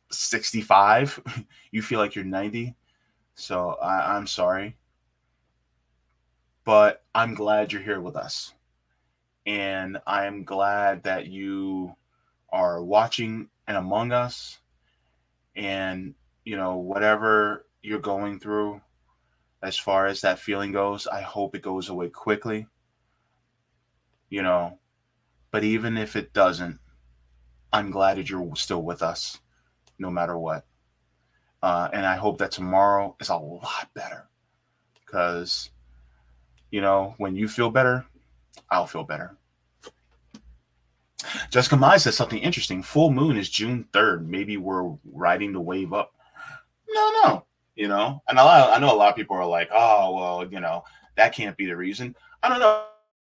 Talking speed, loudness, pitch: 145 wpm, -23 LUFS, 95 Hz